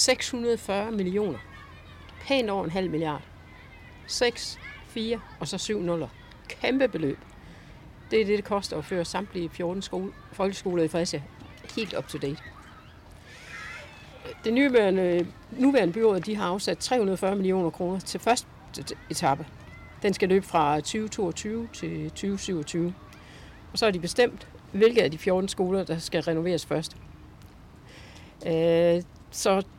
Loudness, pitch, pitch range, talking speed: -27 LUFS, 185 Hz, 160-205 Hz, 135 wpm